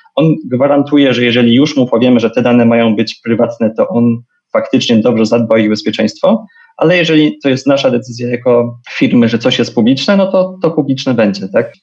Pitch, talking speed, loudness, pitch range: 120 Hz, 195 wpm, -11 LUFS, 115-145 Hz